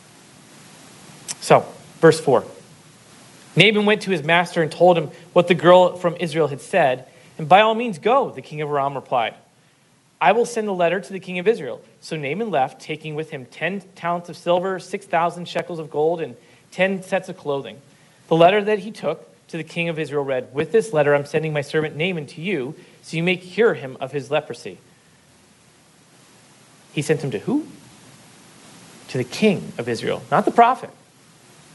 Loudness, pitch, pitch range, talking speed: -20 LUFS, 170 Hz, 155-185 Hz, 185 wpm